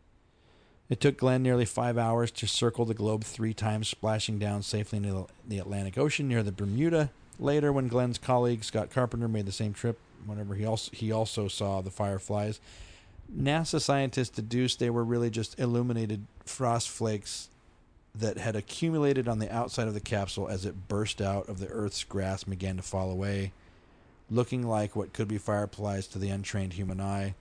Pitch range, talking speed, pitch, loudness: 100-120 Hz, 180 wpm, 110 Hz, -31 LUFS